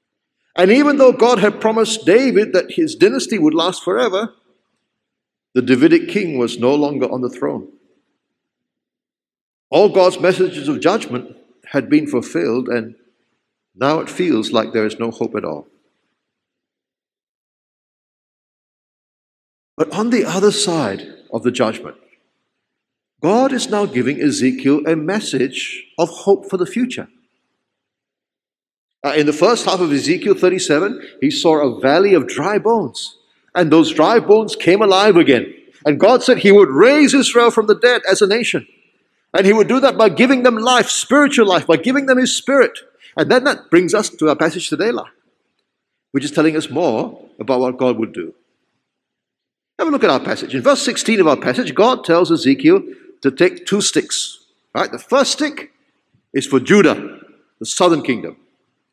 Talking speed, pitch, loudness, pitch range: 165 wpm, 205 Hz, -15 LUFS, 160-255 Hz